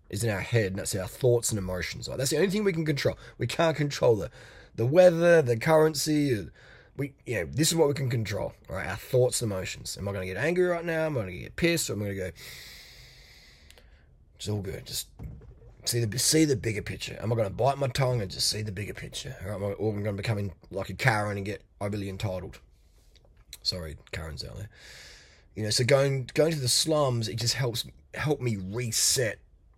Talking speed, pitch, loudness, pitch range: 235 wpm, 115 Hz, -27 LUFS, 100-140 Hz